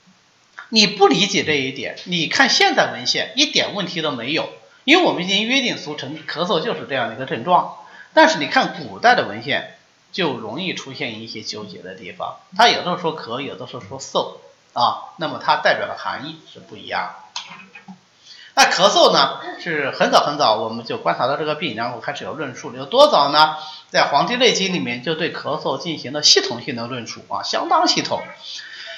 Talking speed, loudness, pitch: 295 characters per minute, -18 LUFS, 200 Hz